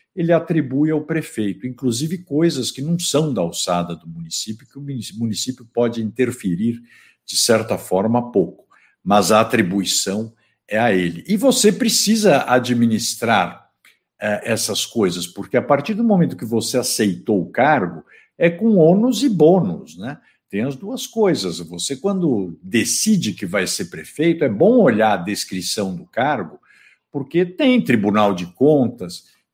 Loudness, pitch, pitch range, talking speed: -18 LUFS, 125 Hz, 105-170 Hz, 150 wpm